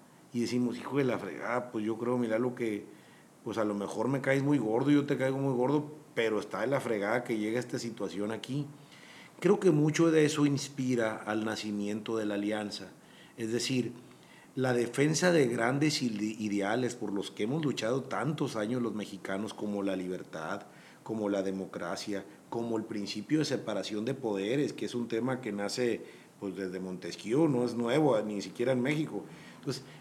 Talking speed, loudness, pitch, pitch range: 185 wpm, -32 LUFS, 115 Hz, 105-135 Hz